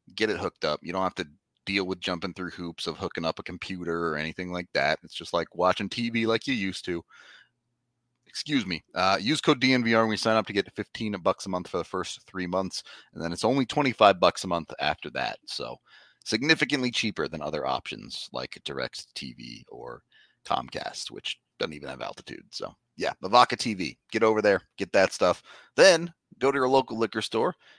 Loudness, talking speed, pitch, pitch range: -27 LUFS, 205 wpm, 105 Hz, 90-120 Hz